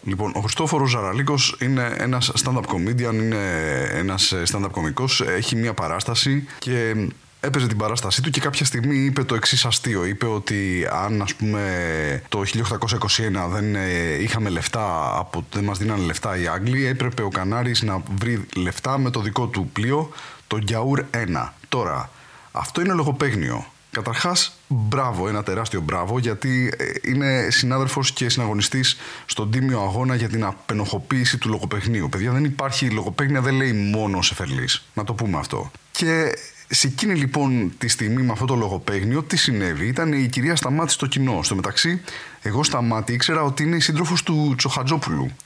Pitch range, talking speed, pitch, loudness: 105-135 Hz, 160 wpm, 120 Hz, -21 LUFS